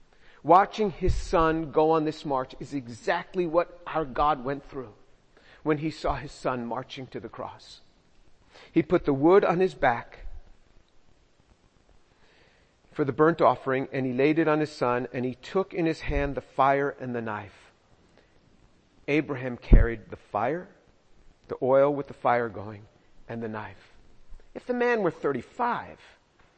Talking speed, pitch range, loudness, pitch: 160 wpm, 120-160 Hz, -26 LUFS, 140 Hz